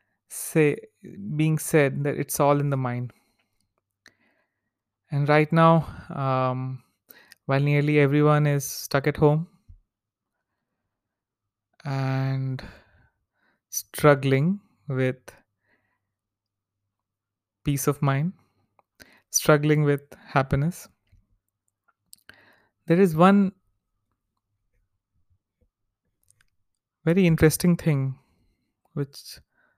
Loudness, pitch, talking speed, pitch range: -23 LUFS, 135 Hz, 75 wpm, 100-150 Hz